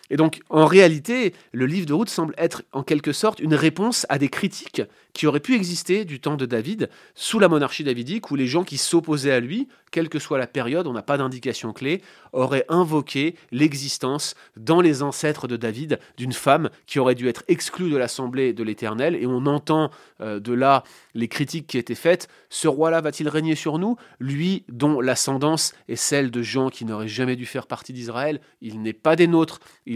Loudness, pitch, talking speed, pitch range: -22 LUFS, 145 Hz, 205 wpm, 130-165 Hz